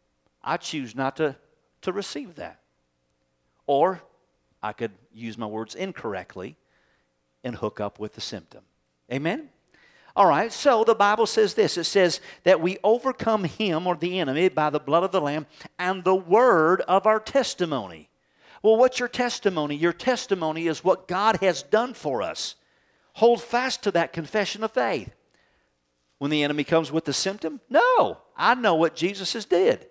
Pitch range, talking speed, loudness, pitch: 135-210 Hz, 165 wpm, -24 LUFS, 175 Hz